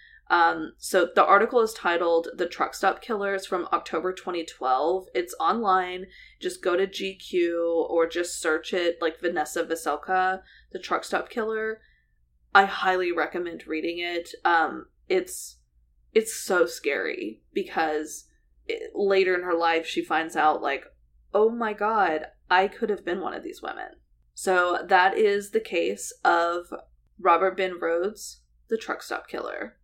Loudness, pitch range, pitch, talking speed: -25 LUFS, 165-220 Hz, 185 Hz, 150 wpm